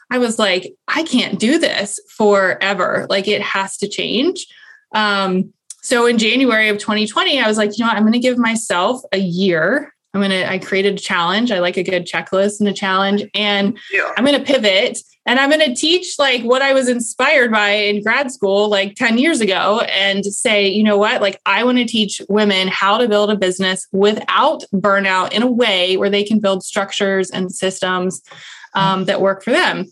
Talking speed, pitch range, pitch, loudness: 205 wpm, 195-245 Hz, 205 Hz, -15 LUFS